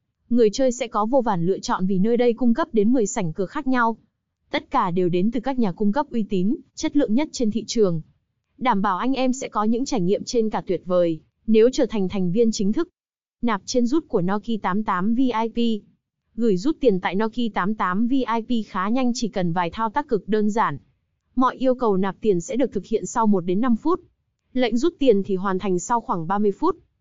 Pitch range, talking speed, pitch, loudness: 195-250 Hz, 230 wpm, 225 Hz, -22 LUFS